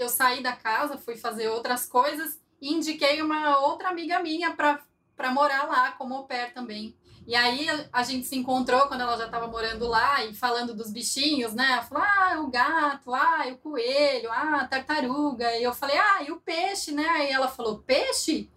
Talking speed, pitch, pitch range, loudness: 200 wpm, 265 Hz, 245-300 Hz, -25 LUFS